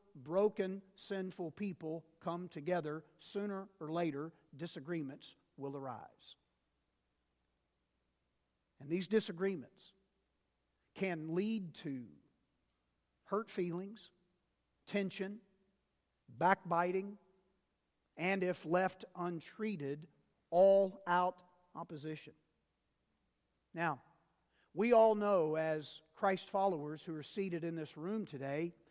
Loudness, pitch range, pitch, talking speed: -38 LUFS, 145-195 Hz, 170 Hz, 85 wpm